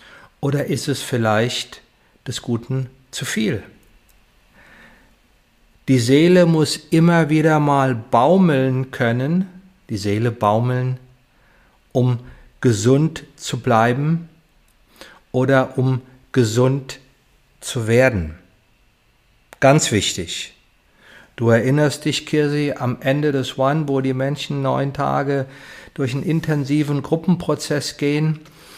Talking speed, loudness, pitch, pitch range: 100 wpm, -19 LUFS, 135 Hz, 125-150 Hz